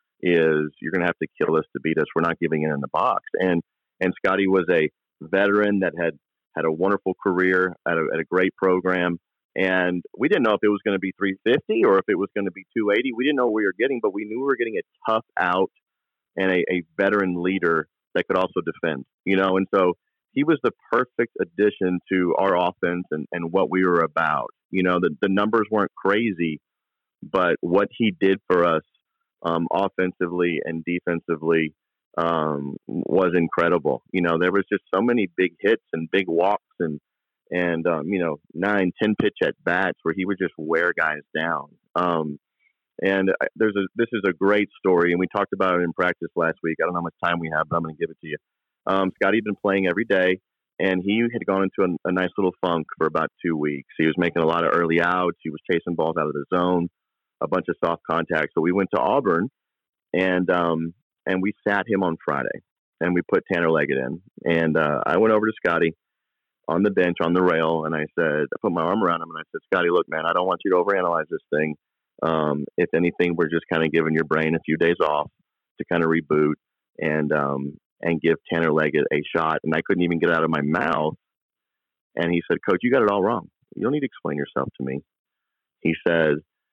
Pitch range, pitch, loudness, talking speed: 80-95 Hz, 90 Hz, -23 LUFS, 230 wpm